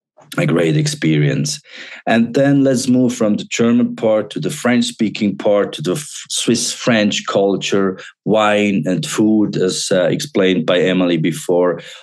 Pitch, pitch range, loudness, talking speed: 105 Hz, 90-120 Hz, -16 LUFS, 155 wpm